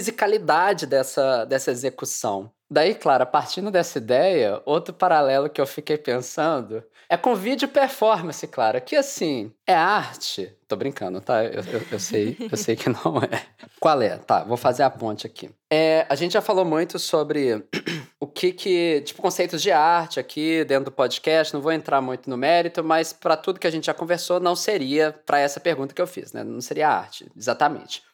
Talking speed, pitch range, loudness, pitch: 190 wpm, 140-180 Hz, -22 LUFS, 160 Hz